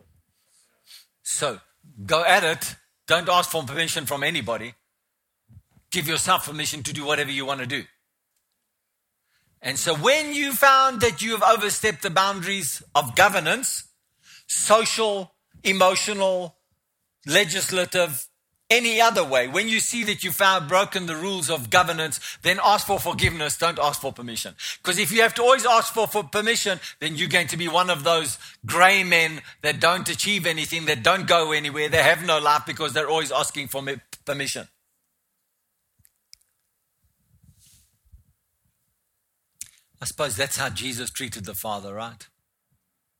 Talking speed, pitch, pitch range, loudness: 145 wpm, 165 Hz, 145-195 Hz, -21 LUFS